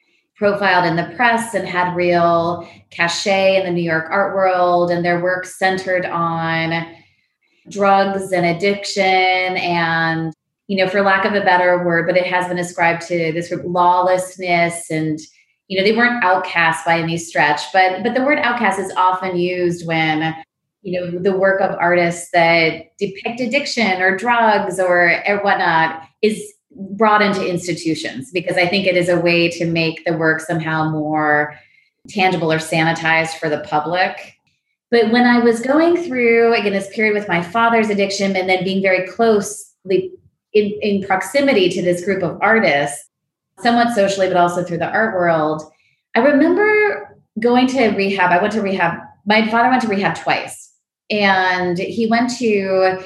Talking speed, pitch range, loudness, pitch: 165 wpm, 170-205 Hz, -16 LUFS, 185 Hz